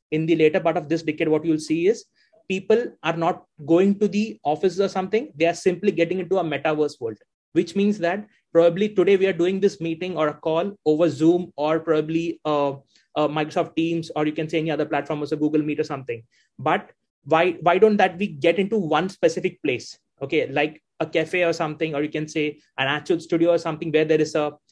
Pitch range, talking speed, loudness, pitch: 155-185 Hz, 225 wpm, -22 LUFS, 165 Hz